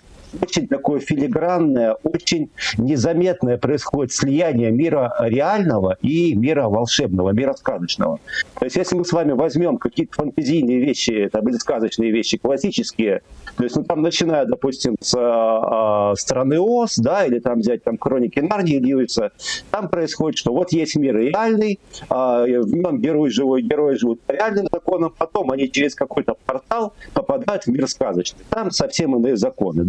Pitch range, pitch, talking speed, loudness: 120-175 Hz, 140 Hz, 160 wpm, -19 LUFS